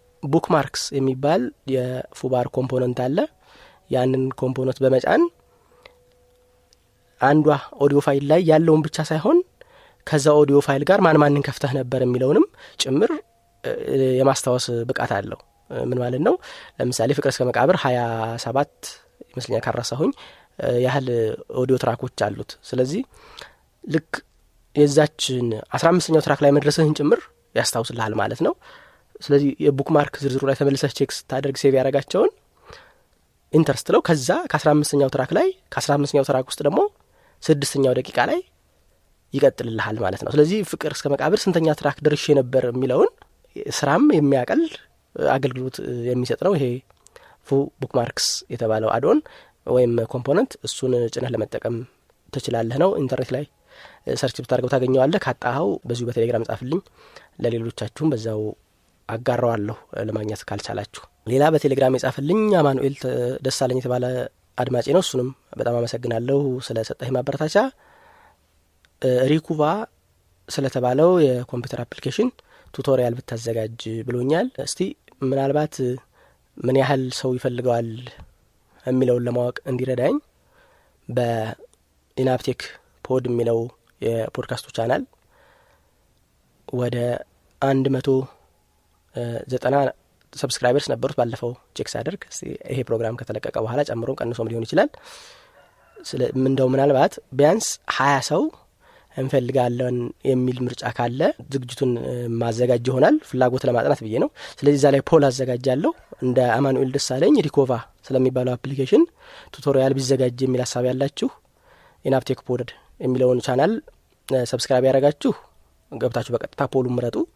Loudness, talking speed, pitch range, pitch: -21 LUFS, 110 wpm, 125-145 Hz, 130 Hz